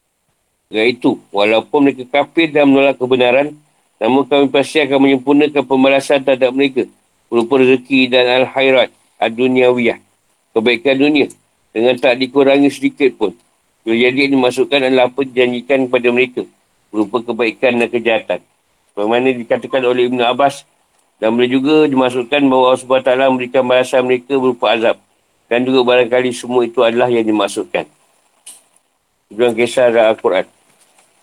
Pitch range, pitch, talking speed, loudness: 125-140 Hz, 130 Hz, 130 wpm, -14 LUFS